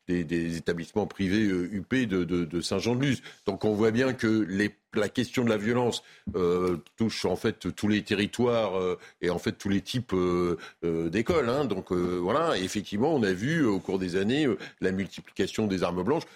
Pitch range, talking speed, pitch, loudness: 90-110 Hz, 205 wpm, 100 Hz, -28 LUFS